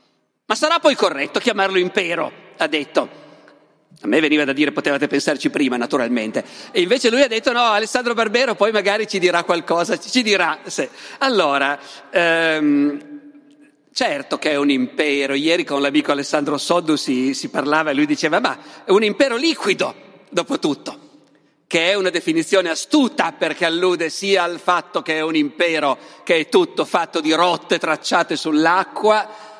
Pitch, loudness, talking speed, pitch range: 175 Hz, -18 LUFS, 160 wpm, 155-230 Hz